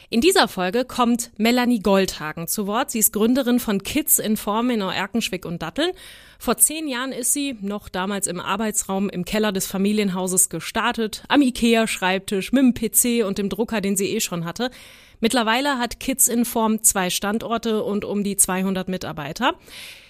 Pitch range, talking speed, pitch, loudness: 195-240 Hz, 180 wpm, 215 Hz, -21 LUFS